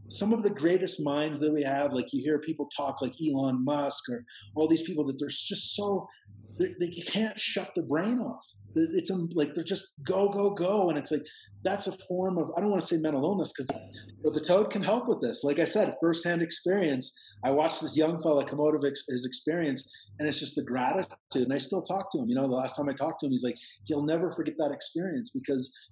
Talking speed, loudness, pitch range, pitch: 240 wpm, -30 LUFS, 140-190 Hz, 160 Hz